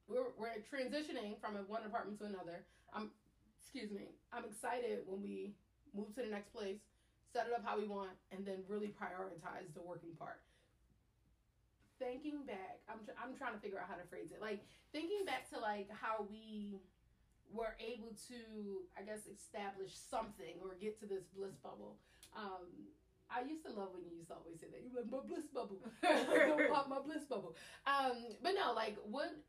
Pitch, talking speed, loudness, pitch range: 215 Hz, 190 wpm, -44 LUFS, 195-245 Hz